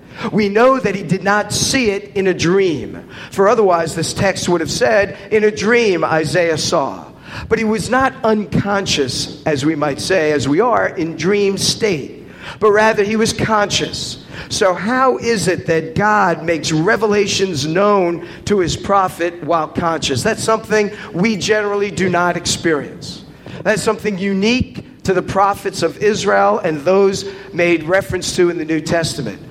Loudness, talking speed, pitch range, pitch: -16 LUFS, 165 wpm, 165-210 Hz, 195 Hz